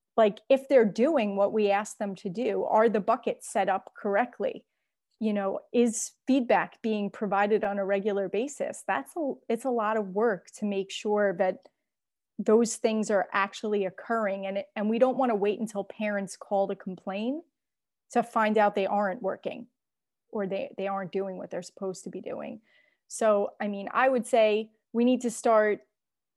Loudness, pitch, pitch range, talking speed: -28 LUFS, 215 Hz, 200-235 Hz, 185 wpm